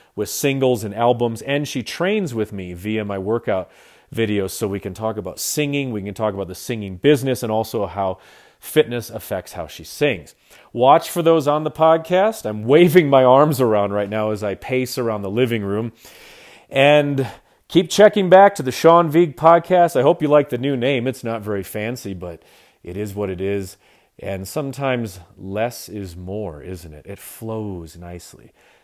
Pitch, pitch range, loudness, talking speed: 115 Hz, 100-140 Hz, -18 LUFS, 185 wpm